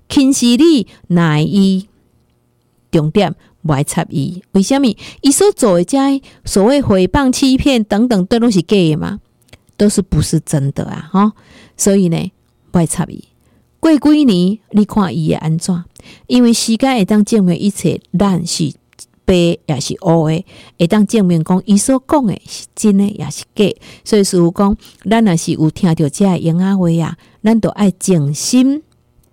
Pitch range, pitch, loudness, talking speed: 170-225 Hz, 195 Hz, -13 LUFS, 225 characters per minute